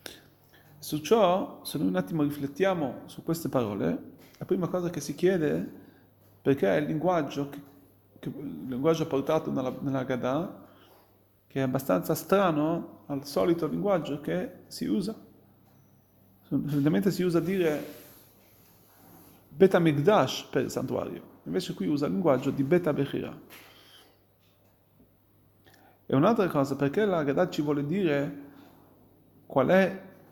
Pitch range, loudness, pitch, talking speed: 130-170 Hz, -28 LUFS, 145 Hz, 135 wpm